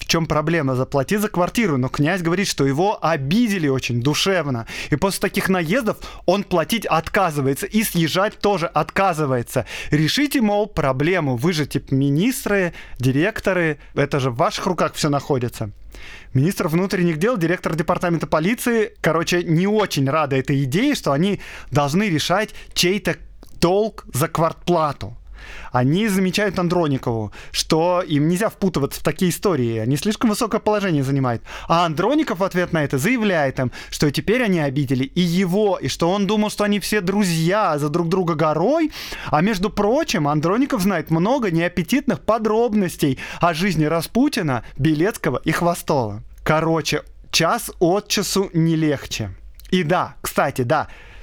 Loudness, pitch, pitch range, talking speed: -20 LUFS, 170 Hz, 145-200 Hz, 145 wpm